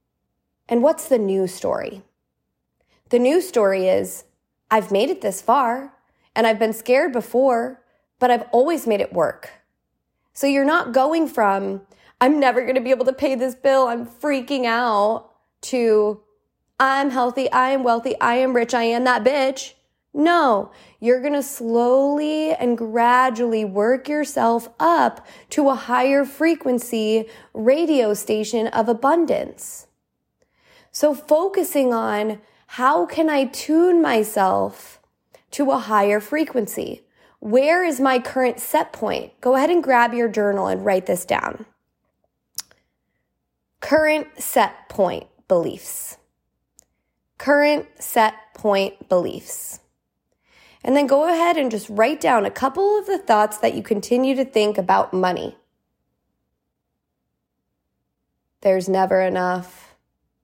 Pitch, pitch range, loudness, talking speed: 245 Hz, 215-275 Hz, -19 LUFS, 130 wpm